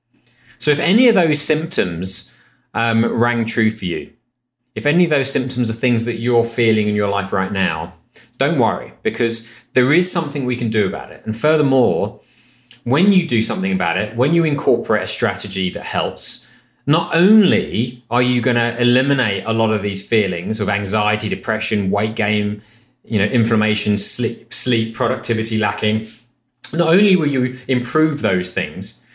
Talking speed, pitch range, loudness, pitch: 170 wpm, 110-130 Hz, -17 LUFS, 120 Hz